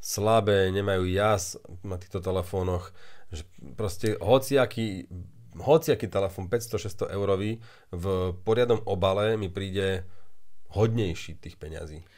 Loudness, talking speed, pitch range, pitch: -27 LUFS, 105 wpm, 90-105 Hz, 95 Hz